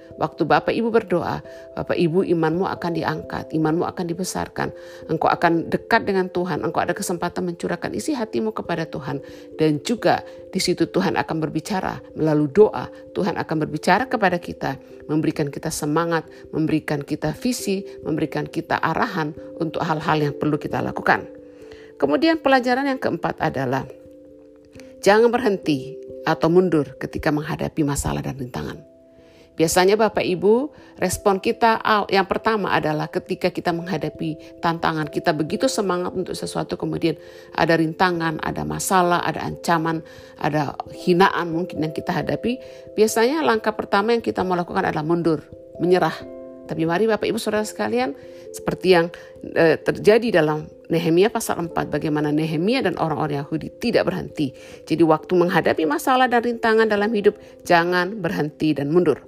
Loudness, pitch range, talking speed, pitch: -21 LUFS, 155-200 Hz, 140 wpm, 170 Hz